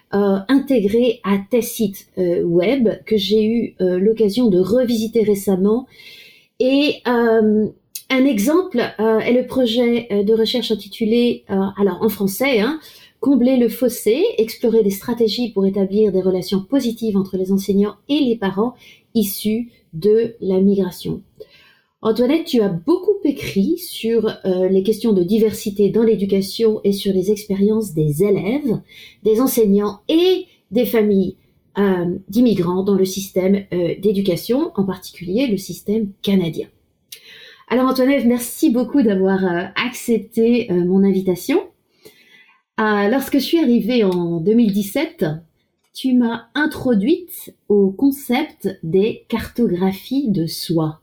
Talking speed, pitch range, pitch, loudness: 135 wpm, 195-245 Hz, 220 Hz, -18 LUFS